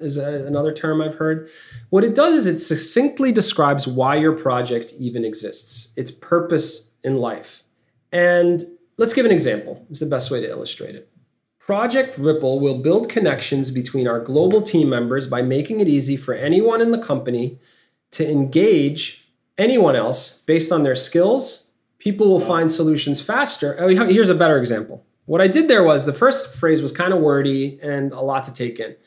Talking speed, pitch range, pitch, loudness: 185 wpm, 135-185 Hz, 155 Hz, -18 LUFS